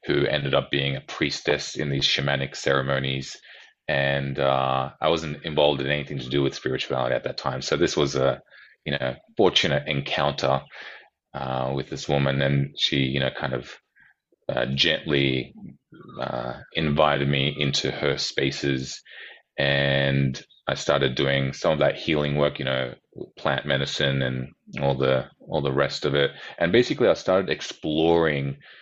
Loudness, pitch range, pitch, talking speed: -24 LUFS, 65-70 Hz, 70 Hz, 160 wpm